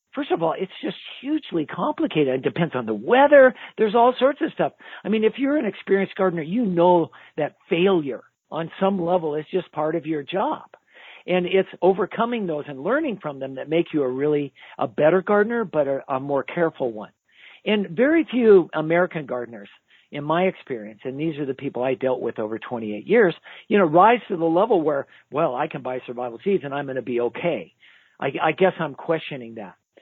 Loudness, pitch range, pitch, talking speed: -22 LUFS, 140-200 Hz, 165 Hz, 205 wpm